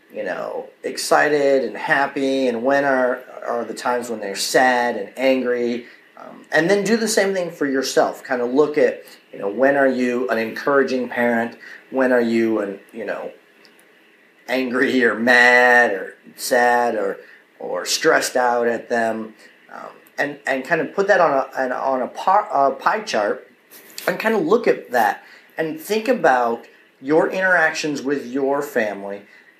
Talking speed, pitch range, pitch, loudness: 165 wpm, 120-160 Hz, 130 Hz, -19 LUFS